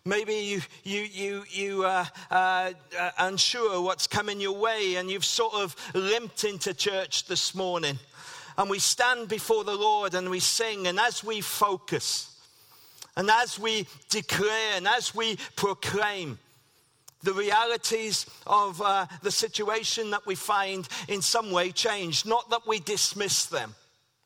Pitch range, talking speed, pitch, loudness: 180-215 Hz, 150 wpm, 200 Hz, -27 LUFS